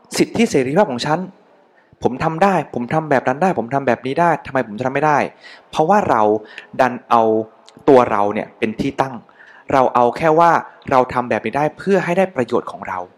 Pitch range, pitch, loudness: 120-170 Hz, 140 Hz, -17 LUFS